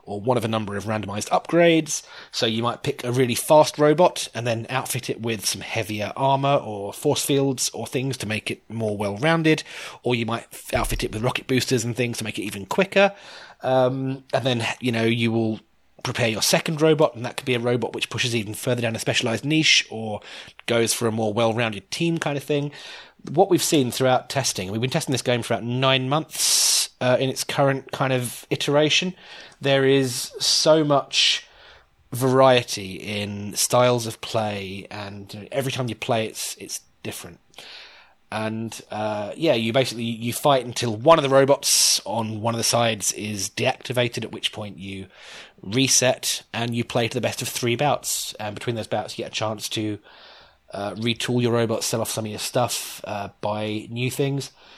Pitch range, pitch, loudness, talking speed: 110-135 Hz, 120 Hz, -22 LUFS, 195 wpm